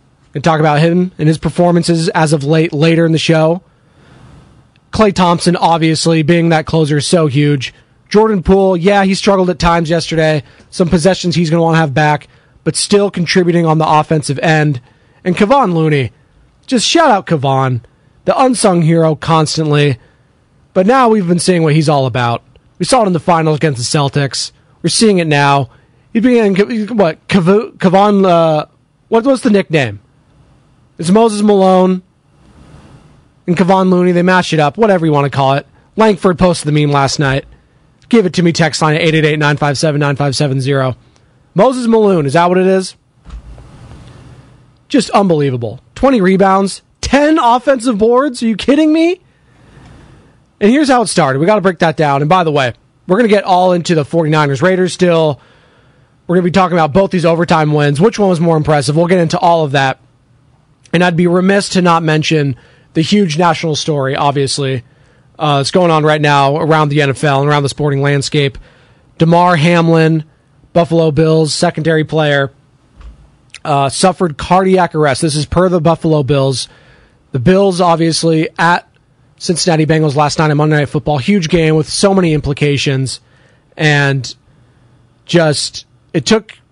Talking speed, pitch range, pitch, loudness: 170 wpm, 140-185 Hz, 160 Hz, -11 LUFS